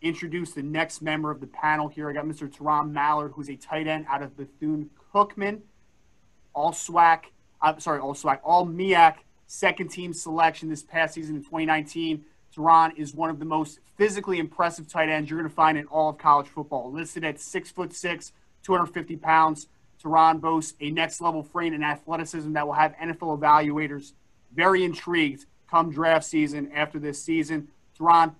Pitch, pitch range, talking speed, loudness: 160 Hz, 150-165 Hz, 180 wpm, -25 LUFS